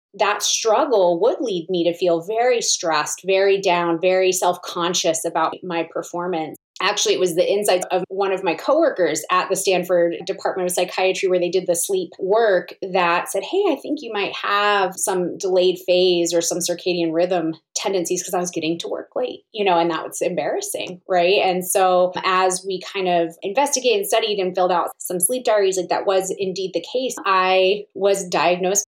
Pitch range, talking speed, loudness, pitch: 175-195 Hz, 195 wpm, -20 LUFS, 185 Hz